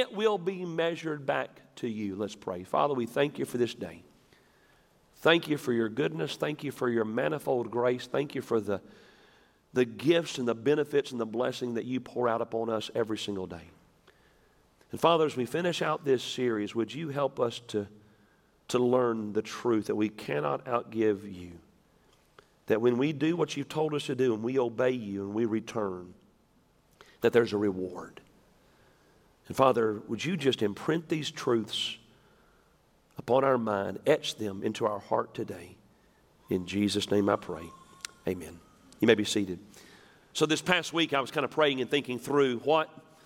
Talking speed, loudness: 180 wpm, -30 LUFS